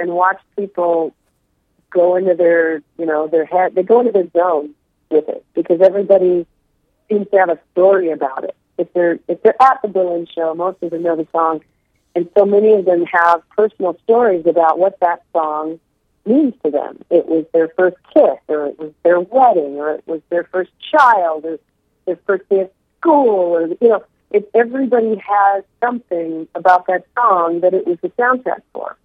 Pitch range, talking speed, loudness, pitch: 165-200 Hz, 190 wpm, -15 LUFS, 180 Hz